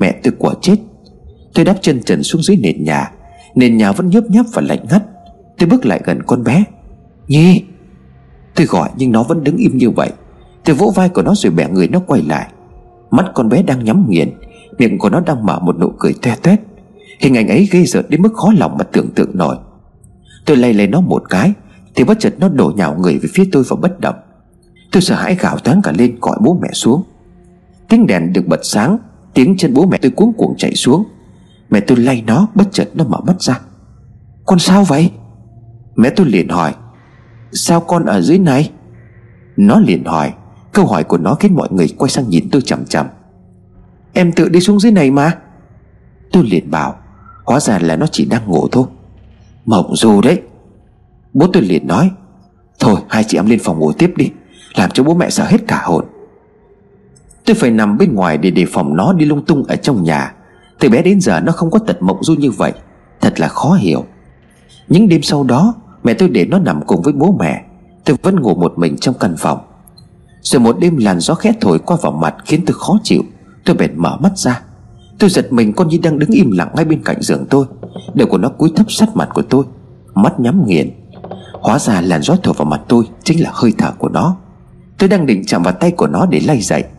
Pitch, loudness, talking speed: 170 Hz, -12 LUFS, 220 wpm